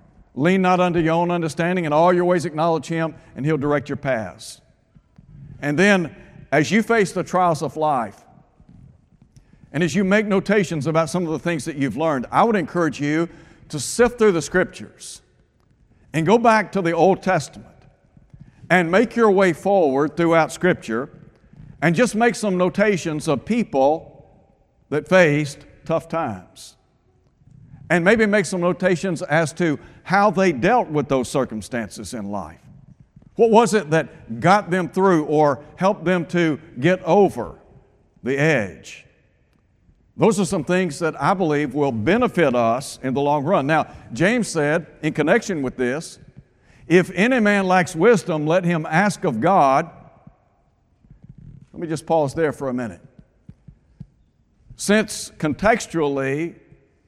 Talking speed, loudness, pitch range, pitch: 150 wpm, -19 LUFS, 145-185 Hz, 165 Hz